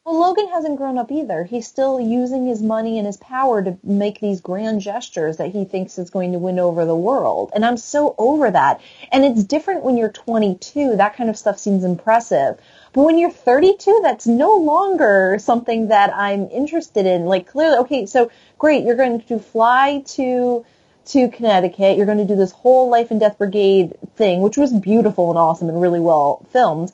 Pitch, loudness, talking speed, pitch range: 225 Hz, -17 LUFS, 200 wpm, 195-260 Hz